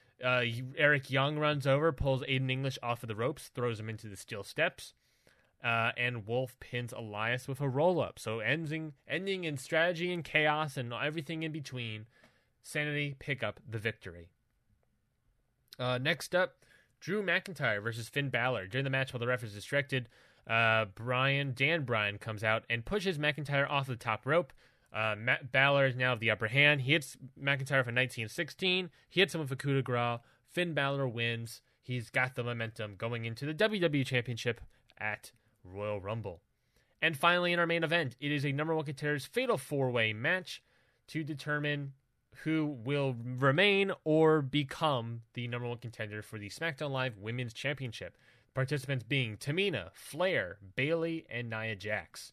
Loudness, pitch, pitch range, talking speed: -32 LUFS, 130 Hz, 115-150 Hz, 170 wpm